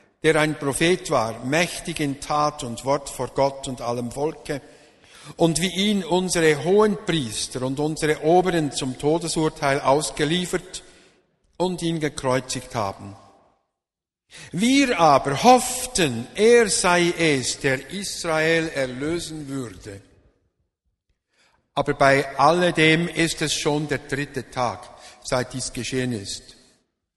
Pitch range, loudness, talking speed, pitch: 125-165 Hz, -22 LUFS, 115 wpm, 150 Hz